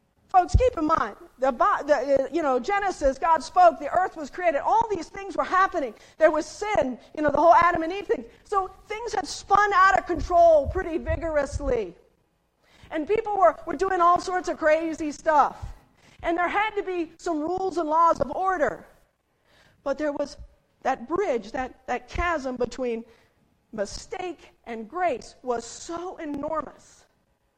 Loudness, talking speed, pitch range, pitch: -24 LUFS, 165 wpm, 290-370 Hz, 335 Hz